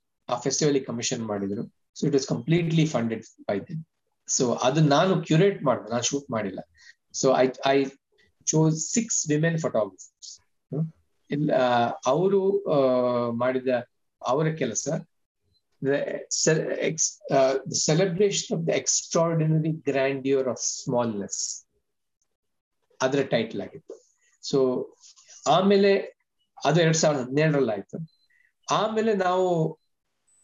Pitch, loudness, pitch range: 145 Hz, -25 LUFS, 125-175 Hz